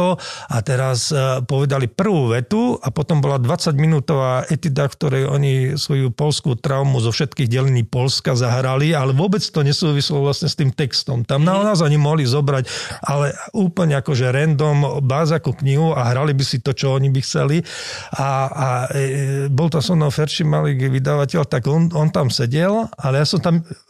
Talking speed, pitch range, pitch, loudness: 180 wpm, 135-155 Hz, 140 Hz, -18 LUFS